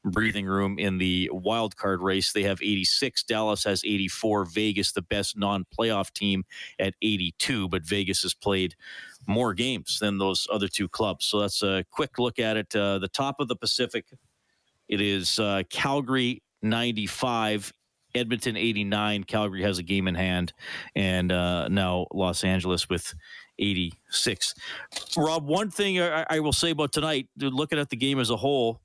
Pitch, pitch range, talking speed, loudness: 105 Hz, 95-120 Hz, 170 wpm, -26 LUFS